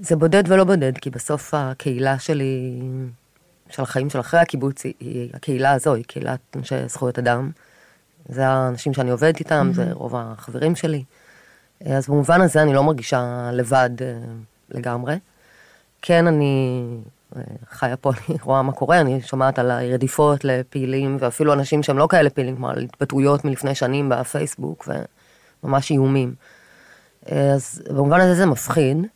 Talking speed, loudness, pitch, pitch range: 145 wpm, -20 LUFS, 135 Hz, 125-155 Hz